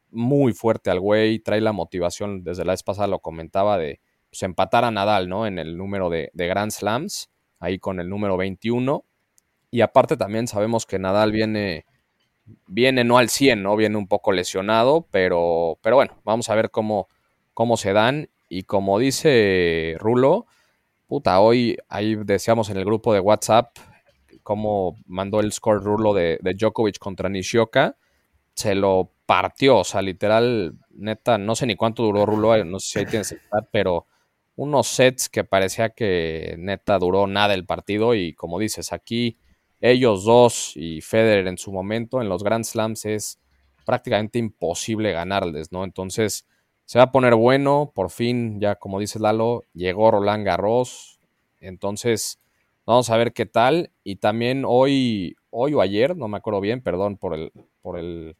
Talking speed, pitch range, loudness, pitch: 170 wpm, 95-115 Hz, -21 LUFS, 105 Hz